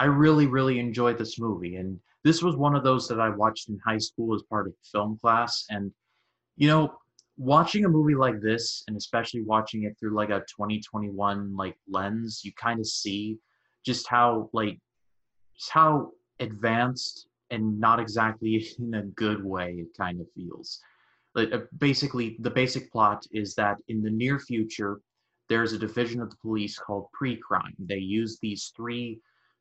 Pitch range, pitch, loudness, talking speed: 105-120 Hz, 110 Hz, -27 LUFS, 175 wpm